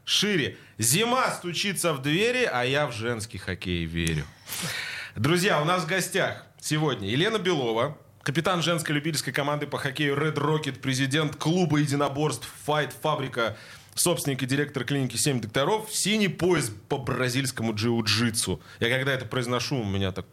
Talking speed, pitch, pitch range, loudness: 150 wpm, 140 Hz, 120-155 Hz, -26 LUFS